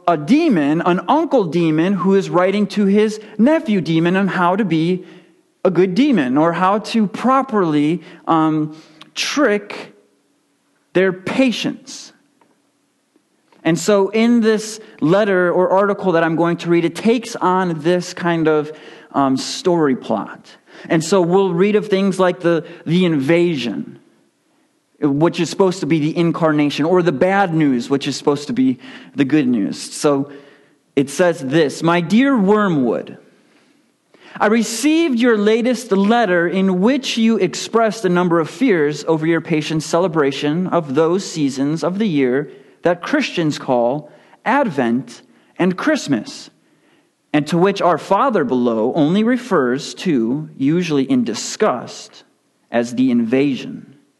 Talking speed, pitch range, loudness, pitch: 140 wpm, 155-220 Hz, -17 LUFS, 180 Hz